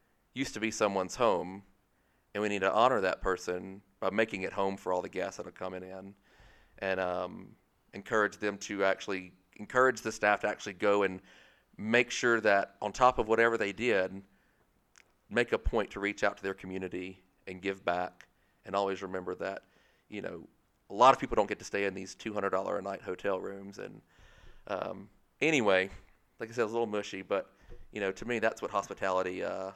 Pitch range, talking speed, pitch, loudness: 95-105 Hz, 200 wpm, 95 Hz, -32 LUFS